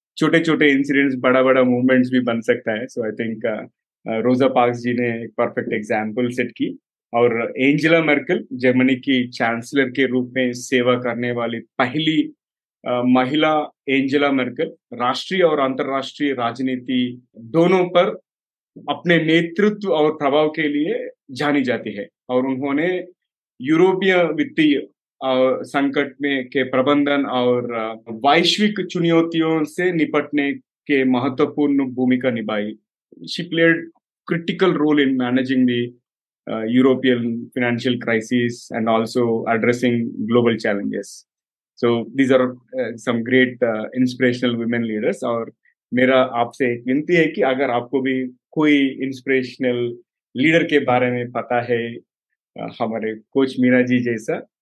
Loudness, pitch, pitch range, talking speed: -19 LUFS, 130 Hz, 120-150 Hz, 125 wpm